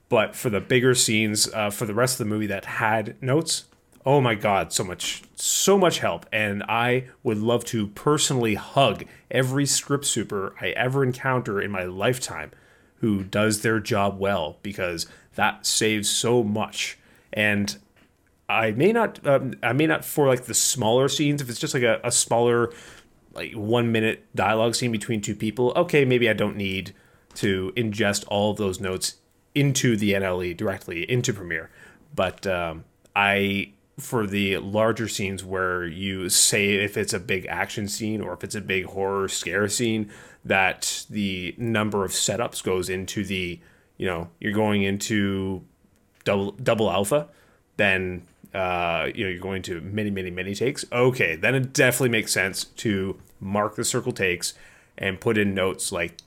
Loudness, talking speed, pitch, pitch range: -24 LUFS, 170 wpm, 105 Hz, 100-120 Hz